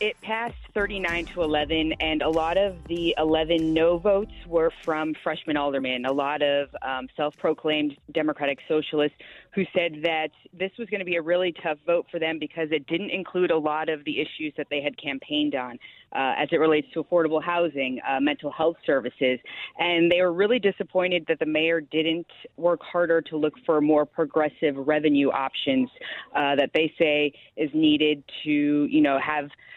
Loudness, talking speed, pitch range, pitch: -25 LUFS, 185 wpm, 150-170 Hz, 160 Hz